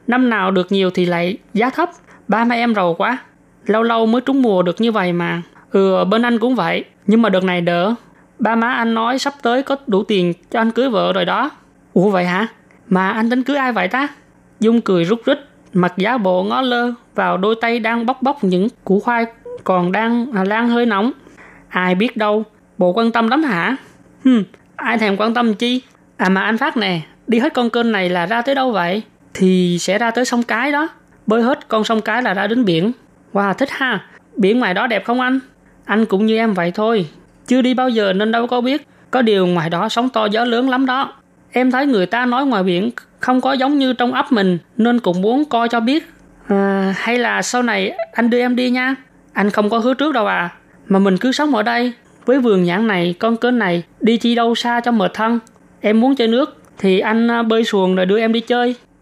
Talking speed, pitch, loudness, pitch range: 230 wpm, 230 Hz, -16 LUFS, 195-245 Hz